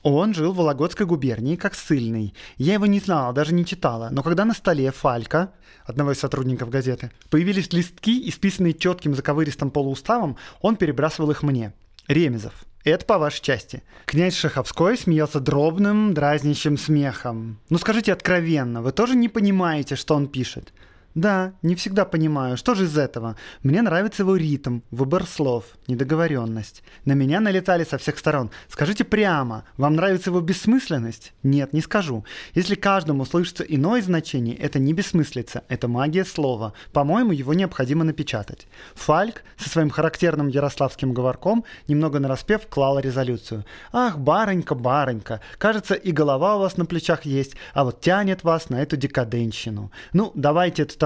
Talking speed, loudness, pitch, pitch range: 155 wpm, -22 LUFS, 150 Hz, 130-180 Hz